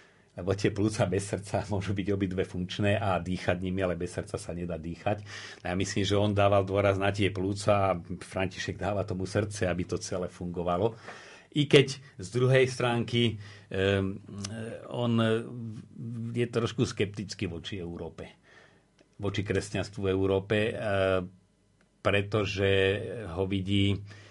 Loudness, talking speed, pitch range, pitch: -29 LUFS, 140 wpm, 95-110 Hz, 100 Hz